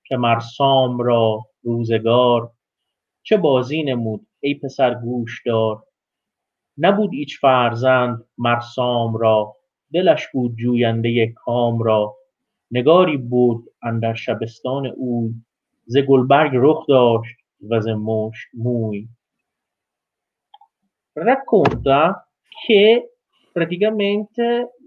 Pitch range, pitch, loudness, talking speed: 115-145 Hz, 120 Hz, -18 LUFS, 85 wpm